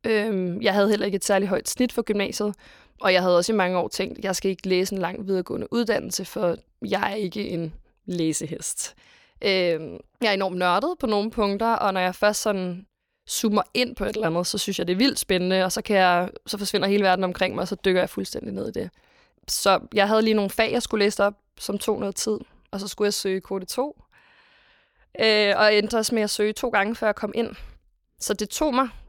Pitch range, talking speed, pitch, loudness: 185-220 Hz, 235 wpm, 200 Hz, -24 LUFS